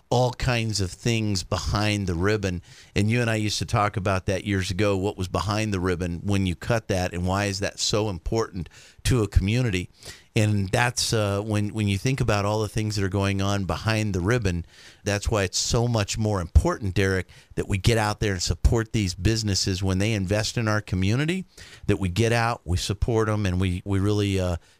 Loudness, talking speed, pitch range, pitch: -25 LUFS, 215 wpm, 95-110 Hz, 100 Hz